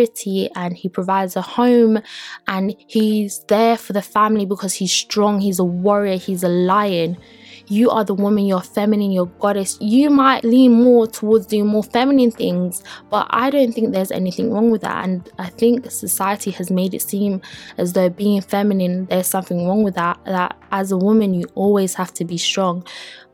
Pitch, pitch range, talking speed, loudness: 200 Hz, 185-220 Hz, 190 wpm, -17 LUFS